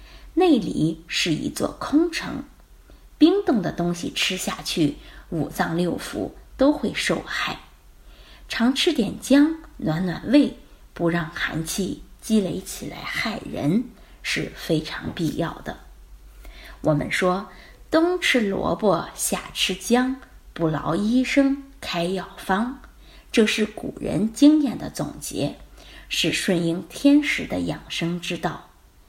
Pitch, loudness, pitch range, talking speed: 190 Hz, -23 LUFS, 170-270 Hz, 170 characters per minute